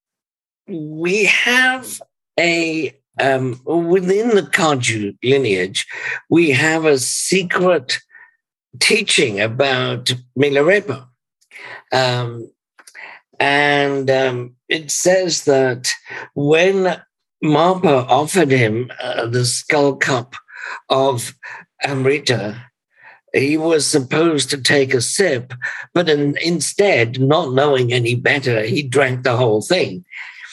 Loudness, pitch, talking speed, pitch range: -16 LUFS, 140 Hz, 100 wpm, 125-170 Hz